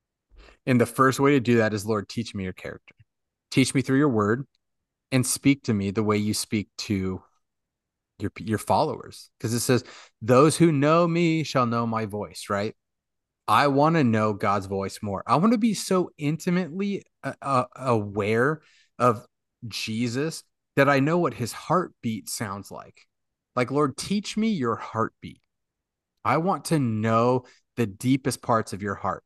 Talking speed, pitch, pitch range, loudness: 170 wpm, 120 Hz, 105-145 Hz, -24 LUFS